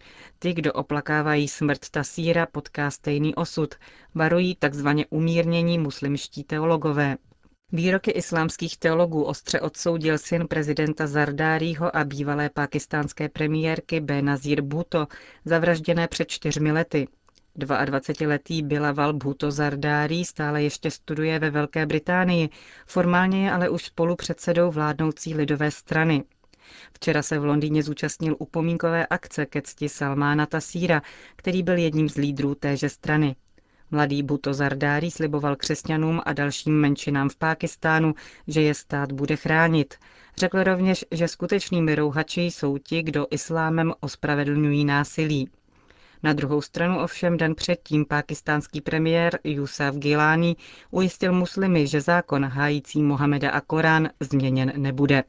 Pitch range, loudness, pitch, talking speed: 145-165 Hz, -24 LUFS, 155 Hz, 125 wpm